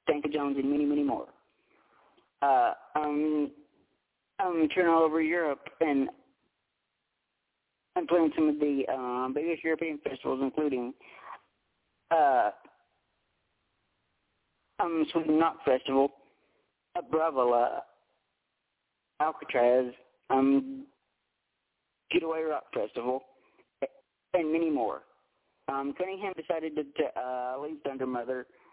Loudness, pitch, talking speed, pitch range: -30 LUFS, 150 Hz, 105 wpm, 135-165 Hz